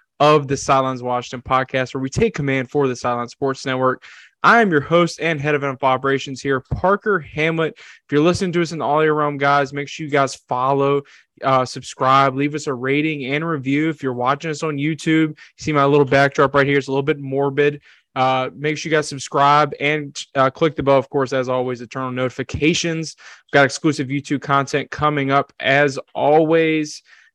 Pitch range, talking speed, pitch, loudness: 135-155 Hz, 210 wpm, 140 Hz, -18 LUFS